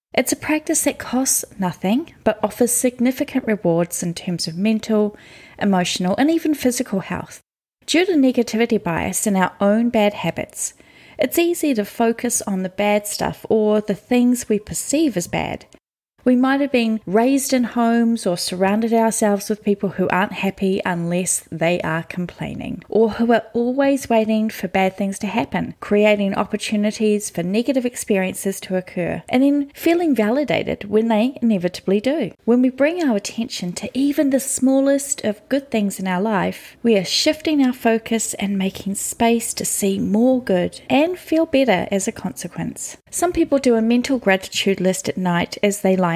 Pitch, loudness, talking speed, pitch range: 220 Hz, -19 LUFS, 170 wpm, 195-255 Hz